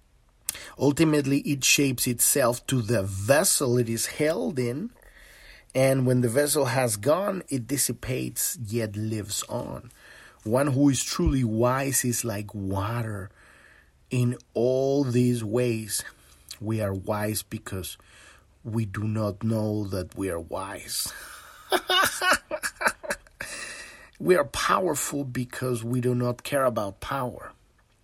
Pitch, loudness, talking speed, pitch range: 120 Hz, -26 LUFS, 120 wpm, 105-130 Hz